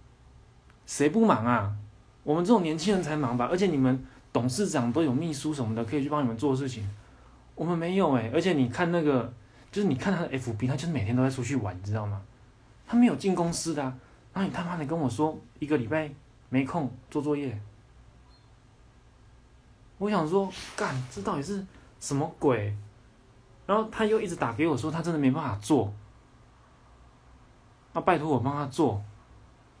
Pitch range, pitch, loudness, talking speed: 115-165 Hz, 135 Hz, -28 LUFS, 270 characters per minute